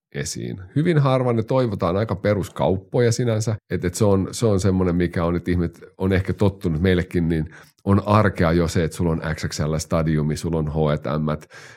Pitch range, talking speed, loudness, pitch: 80-105 Hz, 175 wpm, -21 LUFS, 90 Hz